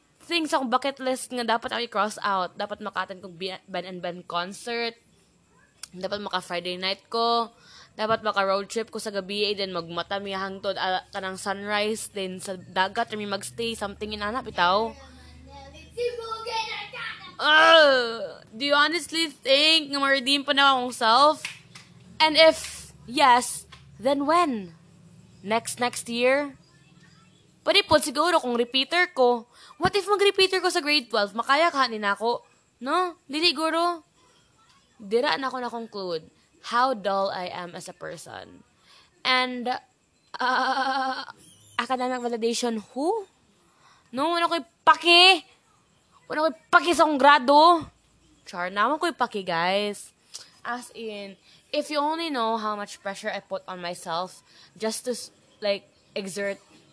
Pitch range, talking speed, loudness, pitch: 195-290 Hz, 140 wpm, -24 LUFS, 235 Hz